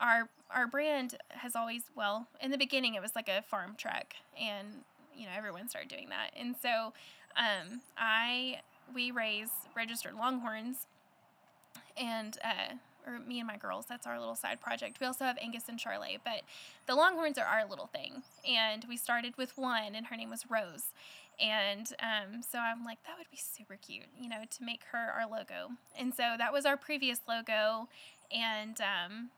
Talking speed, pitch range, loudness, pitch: 185 wpm, 220-270 Hz, -36 LUFS, 235 Hz